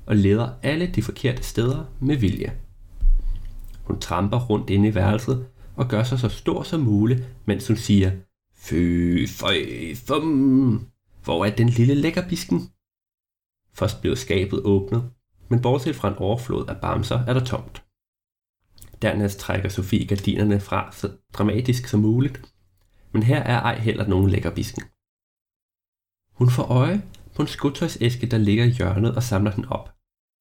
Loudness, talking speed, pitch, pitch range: -22 LUFS, 150 wpm, 105 Hz, 95-120 Hz